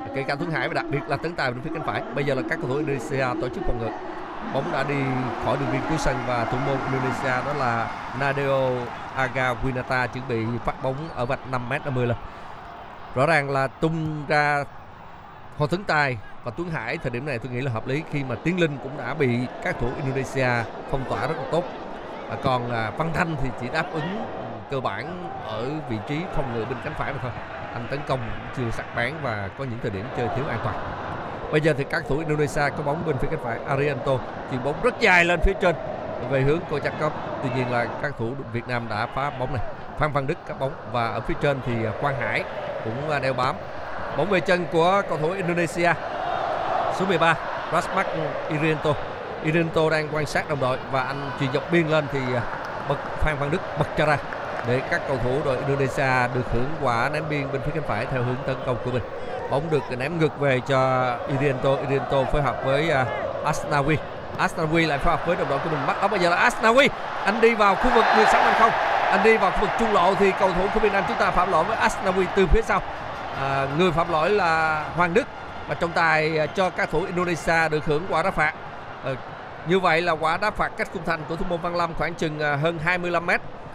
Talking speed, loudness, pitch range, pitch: 235 wpm, -24 LUFS, 125-165 Hz, 140 Hz